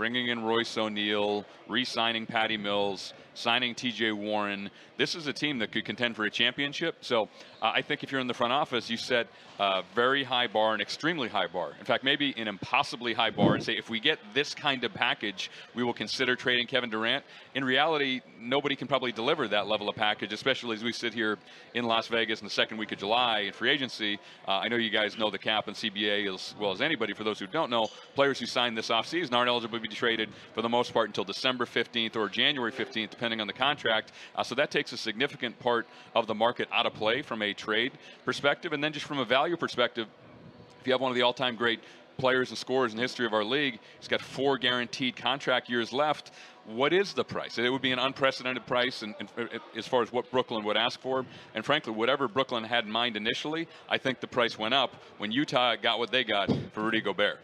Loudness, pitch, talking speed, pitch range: -29 LUFS, 120 Hz, 235 wpm, 110-130 Hz